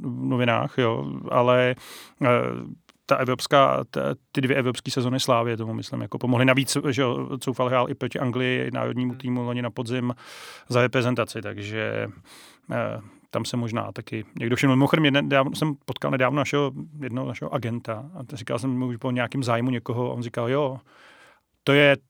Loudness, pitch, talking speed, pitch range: -24 LUFS, 125 Hz, 175 wpm, 120-135 Hz